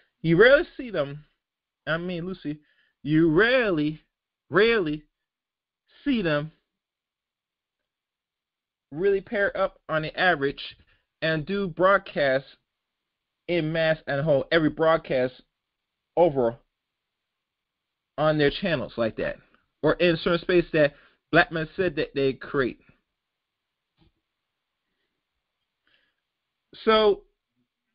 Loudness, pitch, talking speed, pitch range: -24 LUFS, 160 Hz, 100 wpm, 150-190 Hz